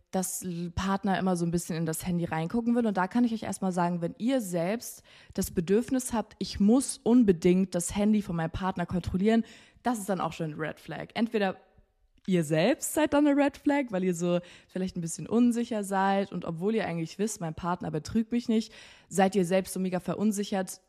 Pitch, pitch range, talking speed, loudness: 190 Hz, 175-225 Hz, 210 wpm, -29 LUFS